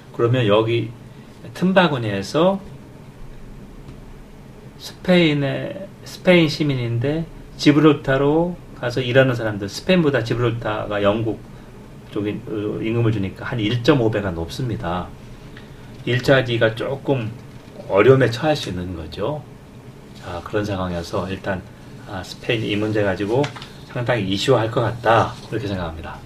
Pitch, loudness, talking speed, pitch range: 115 Hz, -20 LUFS, 265 characters per minute, 105-140 Hz